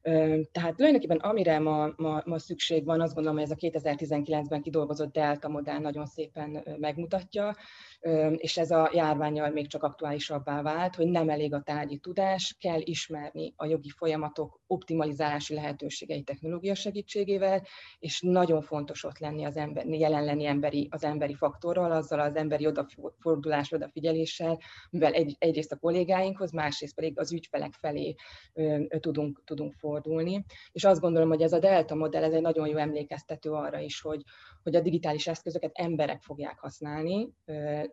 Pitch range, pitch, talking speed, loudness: 150-165 Hz, 155 Hz, 155 wpm, -30 LUFS